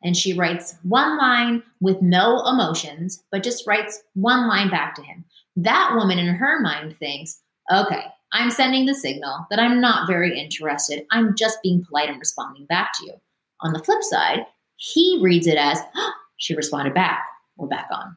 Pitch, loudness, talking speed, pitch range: 185 Hz, -20 LUFS, 185 wpm, 160-240 Hz